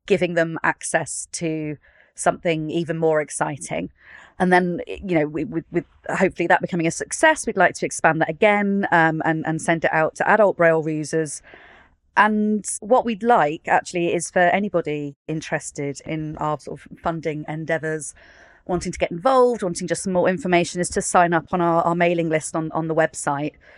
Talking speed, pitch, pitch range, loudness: 180 wpm, 170 Hz, 155-180 Hz, -21 LUFS